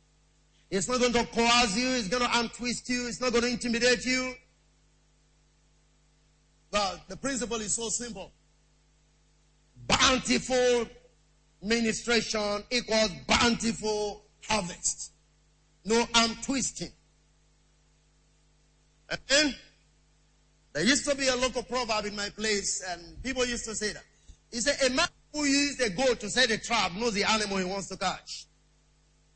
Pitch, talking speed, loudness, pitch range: 230 Hz, 135 wpm, -27 LUFS, 210-250 Hz